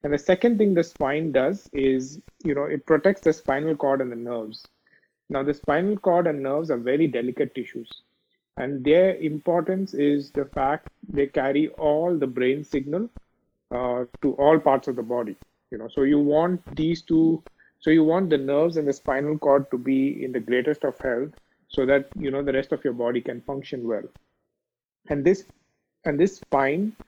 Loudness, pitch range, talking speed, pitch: -24 LUFS, 135-160 Hz, 195 wpm, 145 Hz